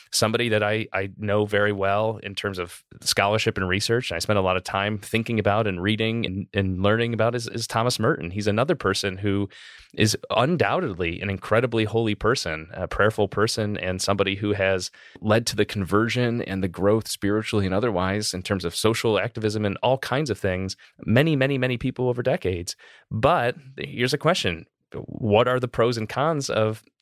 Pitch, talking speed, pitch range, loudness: 105 Hz, 190 wpm, 100-115 Hz, -24 LUFS